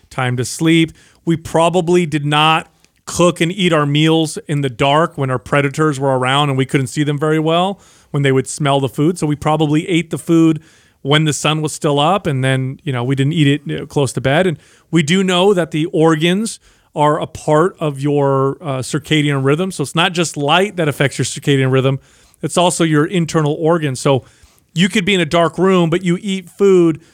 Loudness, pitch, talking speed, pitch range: -15 LUFS, 155 Hz, 215 wpm, 140-170 Hz